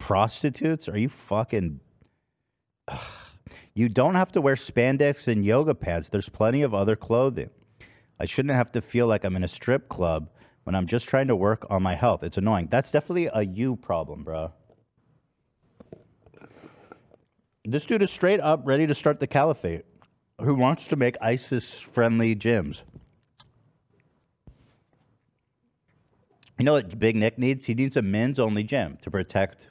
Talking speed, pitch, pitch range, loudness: 160 wpm, 120 Hz, 105-135 Hz, -25 LUFS